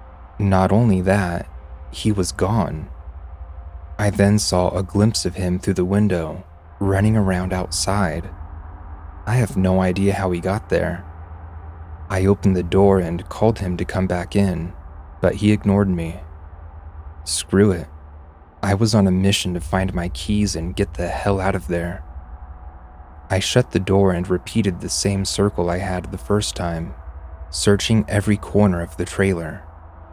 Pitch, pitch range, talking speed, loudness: 90 Hz, 80-100 Hz, 160 wpm, -20 LUFS